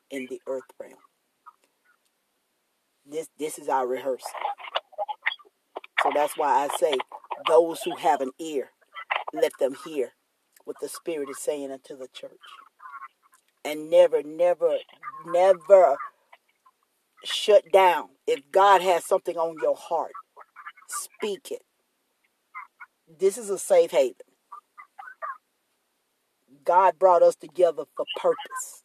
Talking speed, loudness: 115 wpm, -24 LUFS